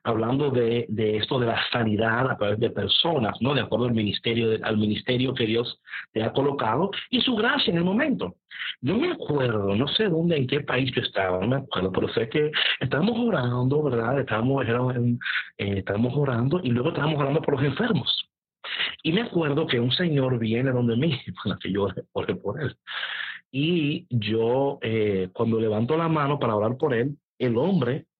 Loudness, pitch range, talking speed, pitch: -25 LUFS, 115-150 Hz, 195 wpm, 125 Hz